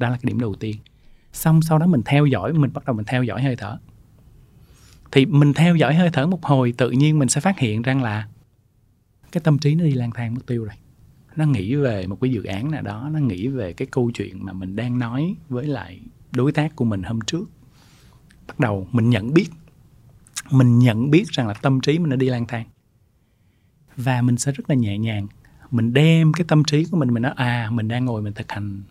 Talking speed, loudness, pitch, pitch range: 235 wpm, -20 LUFS, 125 Hz, 115-145 Hz